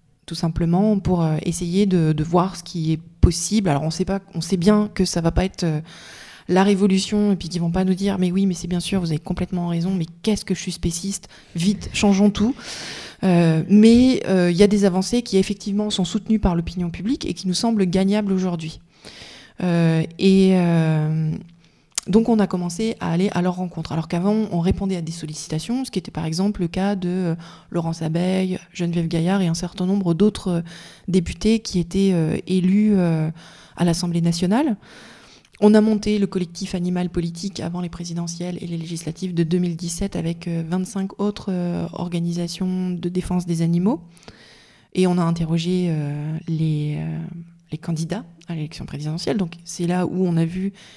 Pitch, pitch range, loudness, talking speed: 180 Hz, 170-195 Hz, -21 LUFS, 190 wpm